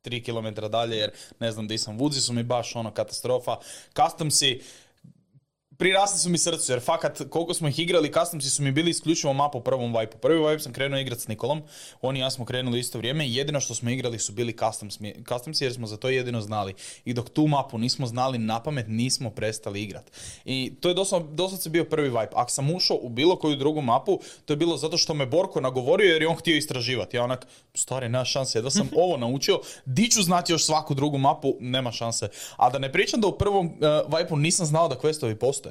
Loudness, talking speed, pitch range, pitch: -25 LUFS, 220 wpm, 120-160 Hz, 135 Hz